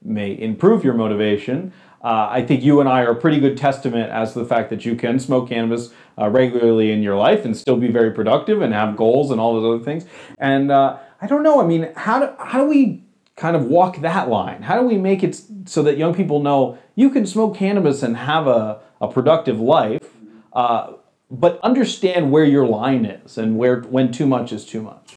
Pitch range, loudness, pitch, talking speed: 115-180 Hz, -18 LUFS, 135 Hz, 225 wpm